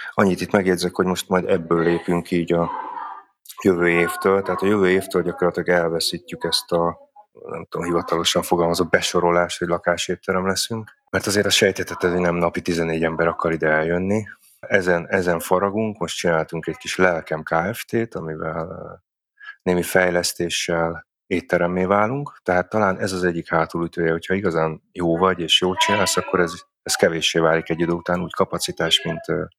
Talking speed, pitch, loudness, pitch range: 155 wpm, 90 Hz, -21 LUFS, 85-95 Hz